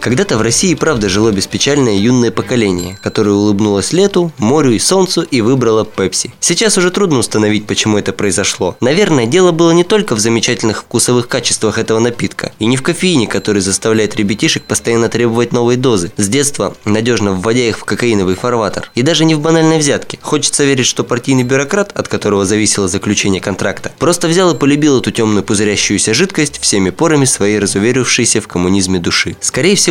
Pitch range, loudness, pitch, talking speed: 105-145 Hz, -12 LUFS, 115 Hz, 175 wpm